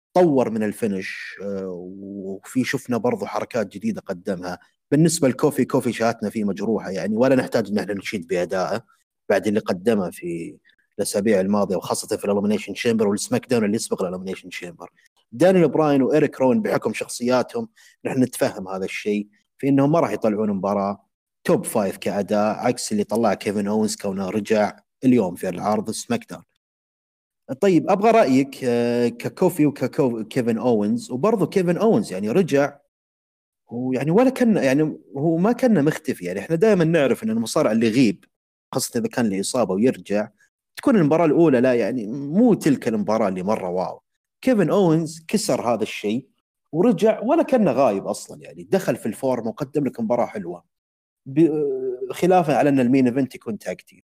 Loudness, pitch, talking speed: -21 LUFS, 130 Hz, 155 wpm